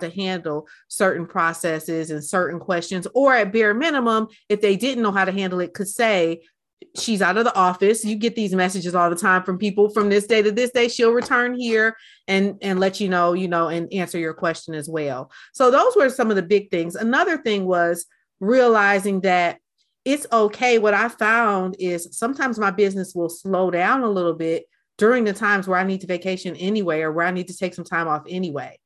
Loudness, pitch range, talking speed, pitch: -20 LUFS, 175-220 Hz, 215 wpm, 195 Hz